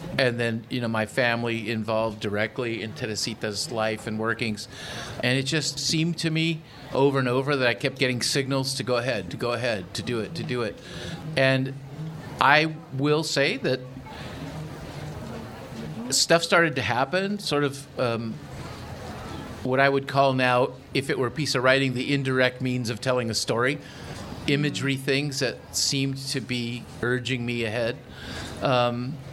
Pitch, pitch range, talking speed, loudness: 130 Hz, 120-140 Hz, 165 wpm, -25 LUFS